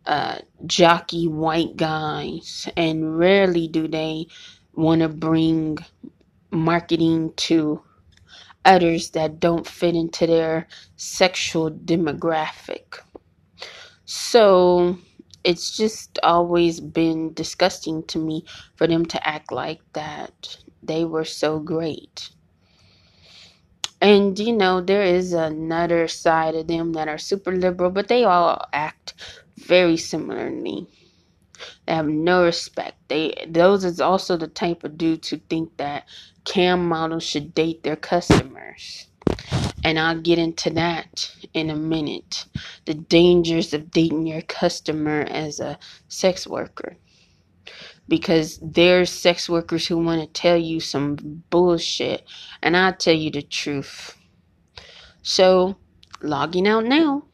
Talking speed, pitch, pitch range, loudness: 125 wpm, 165 Hz, 160-175 Hz, -21 LUFS